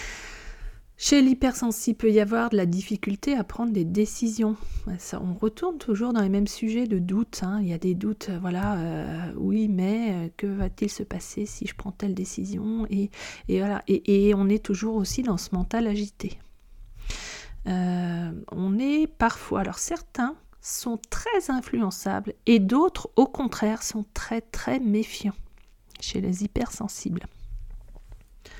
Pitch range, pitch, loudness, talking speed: 190-230 Hz, 210 Hz, -26 LUFS, 155 wpm